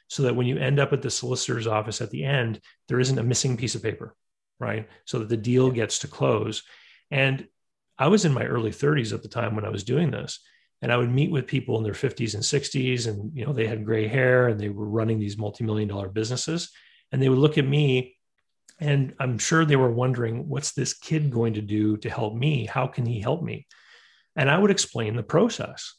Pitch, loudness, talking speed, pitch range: 125 Hz, -25 LUFS, 235 wpm, 110-140 Hz